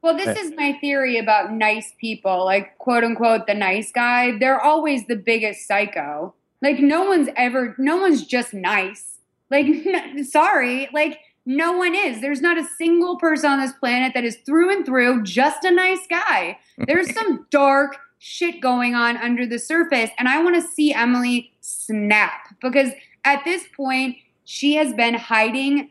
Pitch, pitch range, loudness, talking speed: 270 Hz, 235-310 Hz, -19 LUFS, 175 wpm